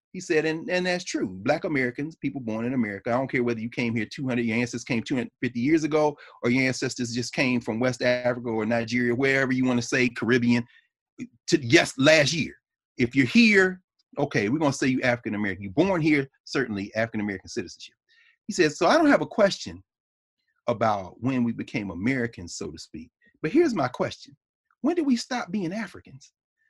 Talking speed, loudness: 200 wpm, -25 LUFS